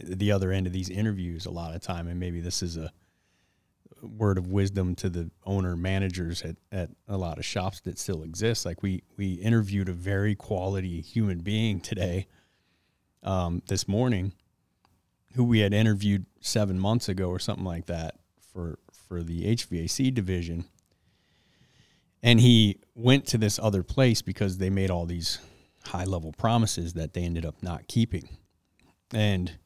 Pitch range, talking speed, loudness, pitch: 85-105 Hz, 165 wpm, -28 LUFS, 95 Hz